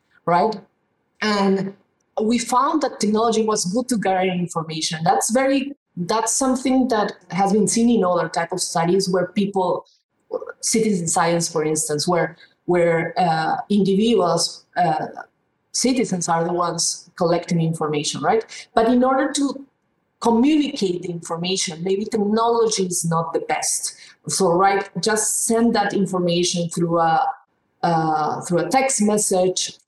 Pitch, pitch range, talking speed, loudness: 195 Hz, 170-230 Hz, 135 wpm, -20 LUFS